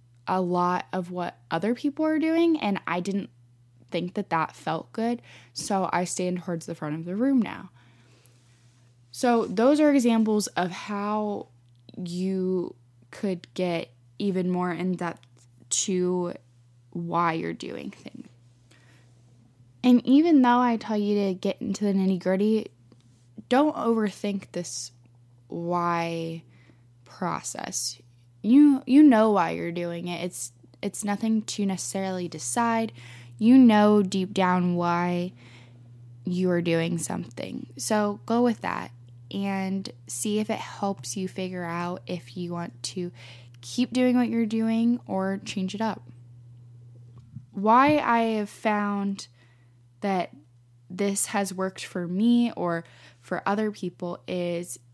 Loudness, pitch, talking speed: -26 LUFS, 180 Hz, 135 wpm